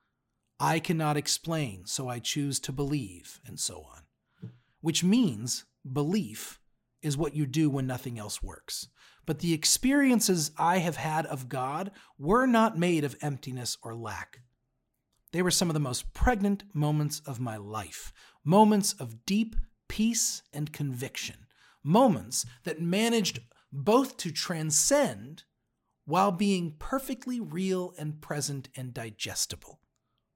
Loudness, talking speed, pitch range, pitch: -29 LUFS, 135 wpm, 130-190 Hz, 150 Hz